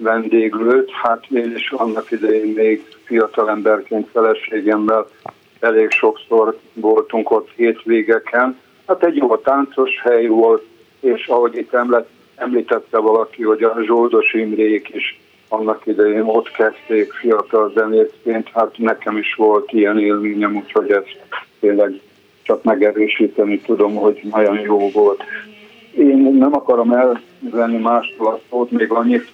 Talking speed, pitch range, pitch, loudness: 130 wpm, 110-120 Hz, 115 Hz, -16 LUFS